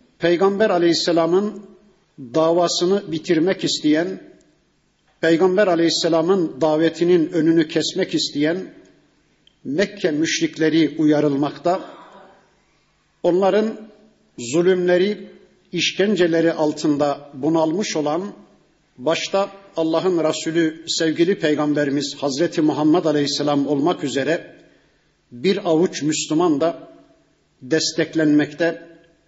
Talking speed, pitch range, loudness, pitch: 70 wpm, 155-185 Hz, -19 LUFS, 165 Hz